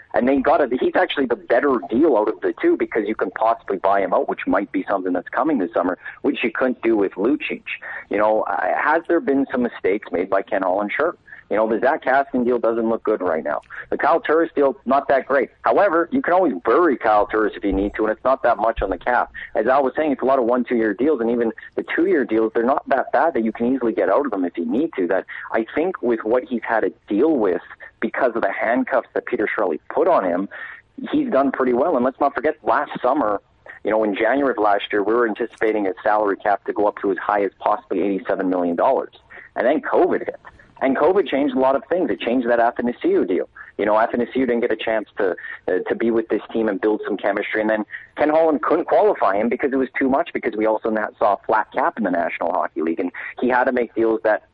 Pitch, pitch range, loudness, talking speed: 125 Hz, 110-170 Hz, -20 LUFS, 260 wpm